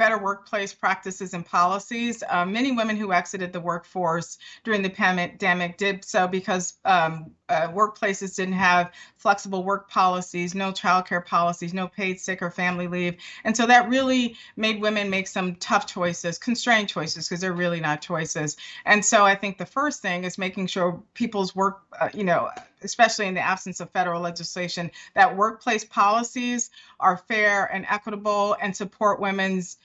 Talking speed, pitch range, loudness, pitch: 170 wpm, 180-210 Hz, -24 LUFS, 190 Hz